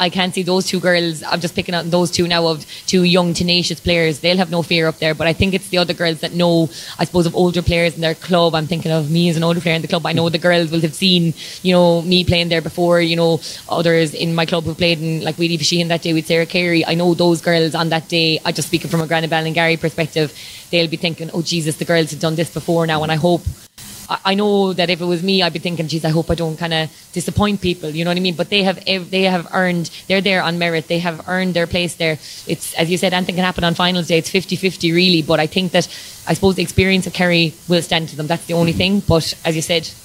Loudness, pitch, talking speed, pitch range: -16 LUFS, 170 Hz, 285 wpm, 165-180 Hz